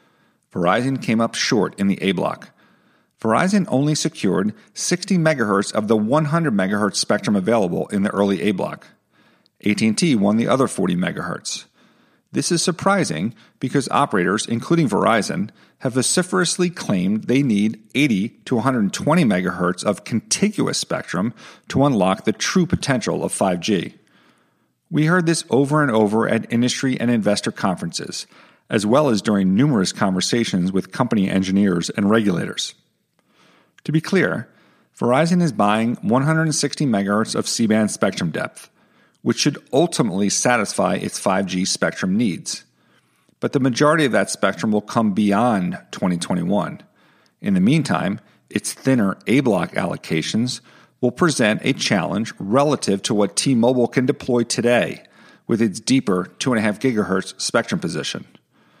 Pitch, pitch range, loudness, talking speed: 120 Hz, 105-160 Hz, -20 LUFS, 140 wpm